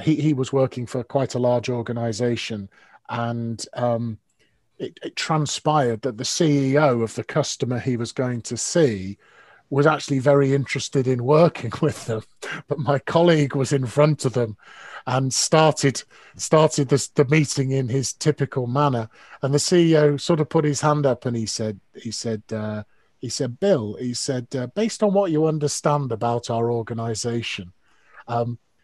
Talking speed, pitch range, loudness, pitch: 165 wpm, 115-150 Hz, -22 LUFS, 130 Hz